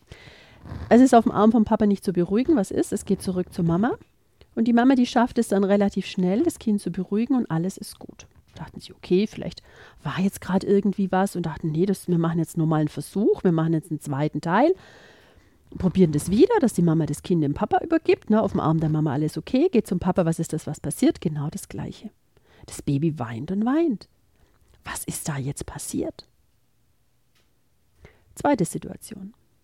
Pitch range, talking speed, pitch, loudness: 155-215 Hz, 205 wpm, 185 Hz, -23 LUFS